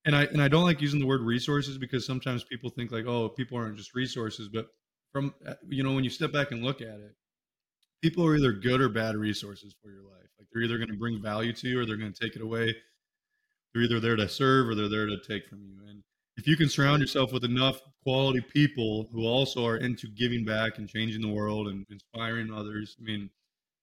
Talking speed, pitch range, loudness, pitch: 240 wpm, 110-135 Hz, -29 LUFS, 120 Hz